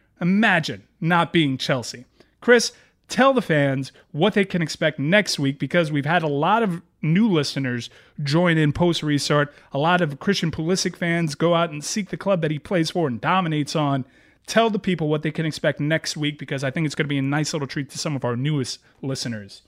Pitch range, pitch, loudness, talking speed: 140-175 Hz, 155 Hz, -22 LUFS, 215 wpm